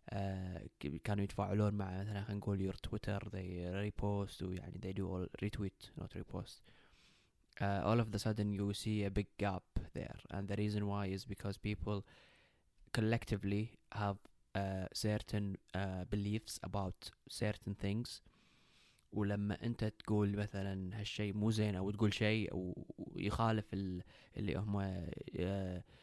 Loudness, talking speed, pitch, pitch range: -41 LUFS, 135 wpm, 100 Hz, 95-105 Hz